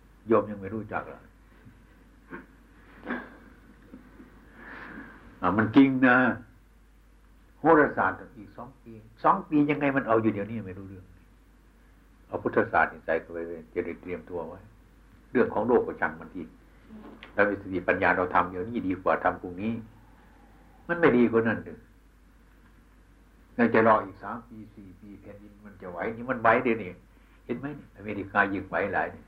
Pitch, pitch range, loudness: 105 Hz, 95-115 Hz, -26 LUFS